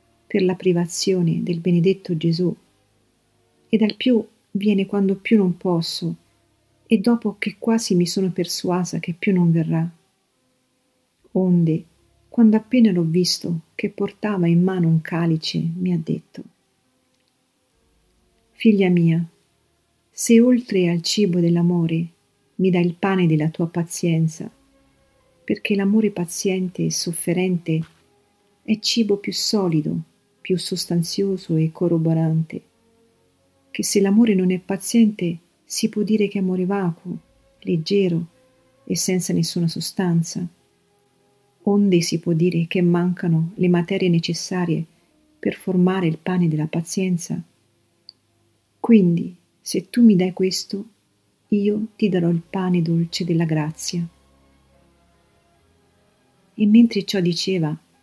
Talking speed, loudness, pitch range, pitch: 120 wpm, -20 LUFS, 165-200 Hz, 175 Hz